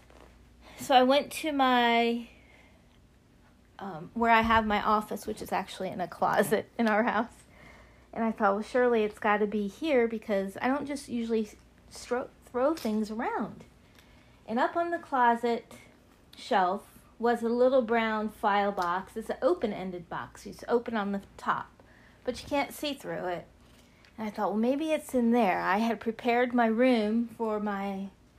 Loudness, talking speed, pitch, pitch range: -29 LUFS, 175 wpm, 225 Hz, 210-245 Hz